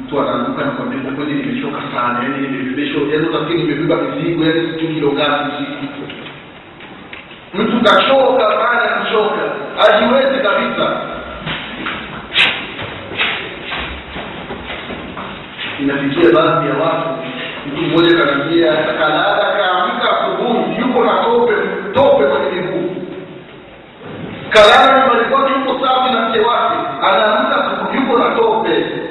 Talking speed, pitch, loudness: 110 wpm, 200 Hz, -14 LUFS